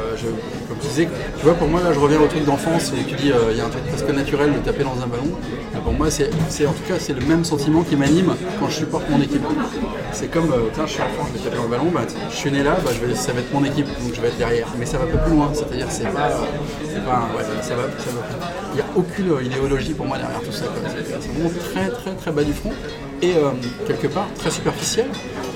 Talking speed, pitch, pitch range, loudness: 265 wpm, 150 Hz, 140-165 Hz, -21 LUFS